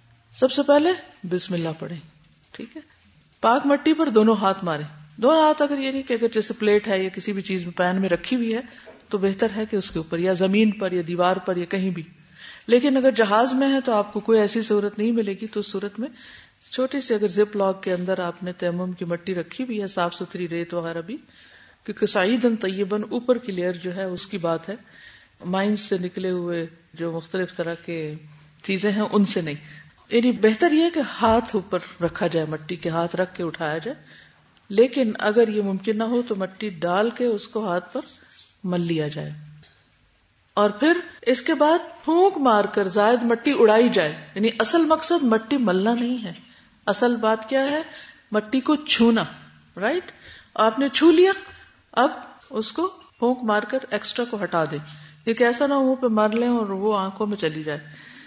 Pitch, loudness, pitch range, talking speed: 210 Hz, -22 LUFS, 180-245 Hz, 205 wpm